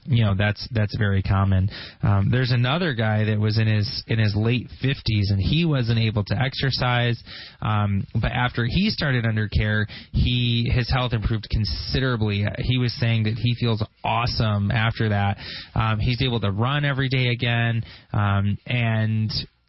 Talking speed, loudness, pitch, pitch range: 170 wpm, -23 LUFS, 115 Hz, 105-125 Hz